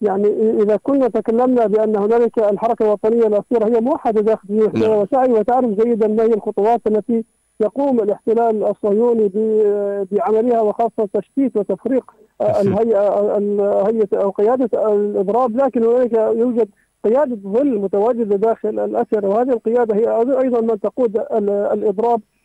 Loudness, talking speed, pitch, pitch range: -17 LUFS, 125 wpm, 220 Hz, 210-235 Hz